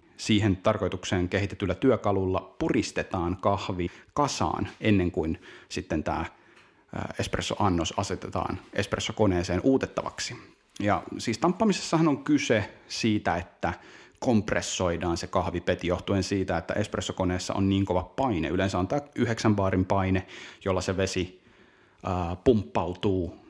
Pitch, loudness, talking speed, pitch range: 95 Hz, -28 LUFS, 110 wpm, 90-110 Hz